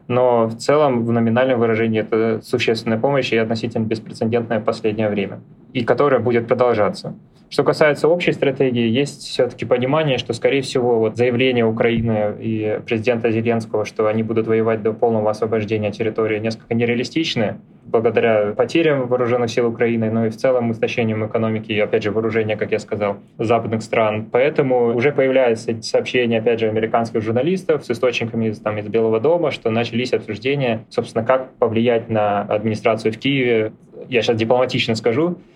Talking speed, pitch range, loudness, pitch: 155 wpm, 110-125 Hz, -19 LUFS, 115 Hz